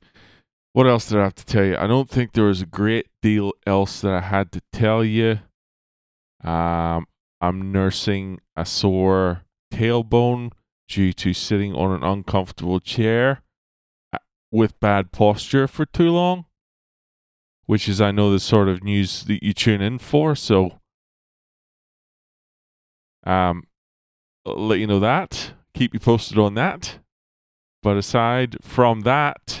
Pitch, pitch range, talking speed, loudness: 100 Hz, 95-115 Hz, 140 wpm, -20 LUFS